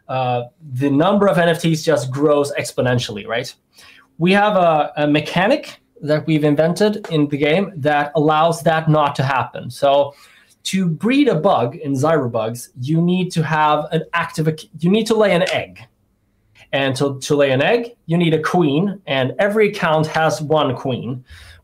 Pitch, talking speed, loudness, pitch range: 155 Hz, 170 wpm, -17 LUFS, 140-170 Hz